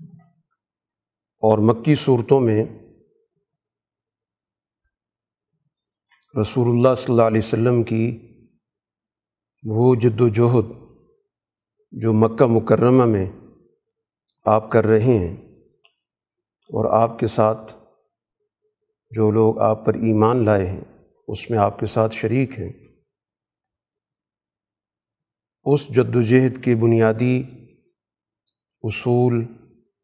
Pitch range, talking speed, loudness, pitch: 110-130 Hz, 95 wpm, -19 LUFS, 115 Hz